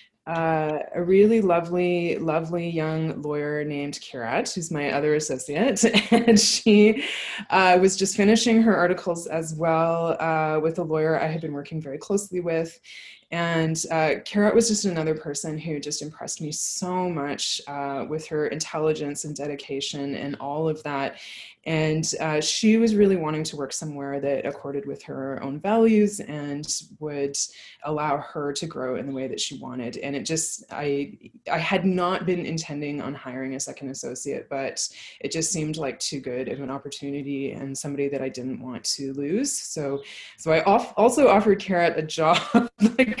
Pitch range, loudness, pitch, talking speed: 145-180 Hz, -24 LUFS, 155 Hz, 175 wpm